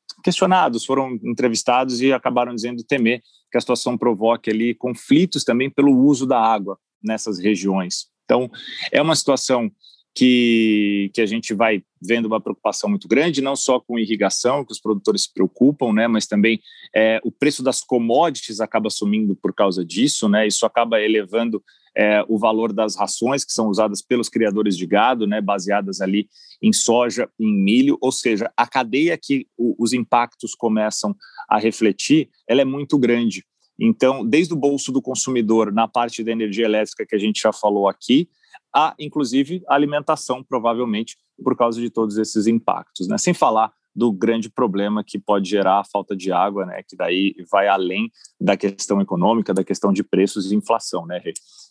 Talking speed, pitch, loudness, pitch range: 175 wpm, 115 Hz, -19 LUFS, 105-125 Hz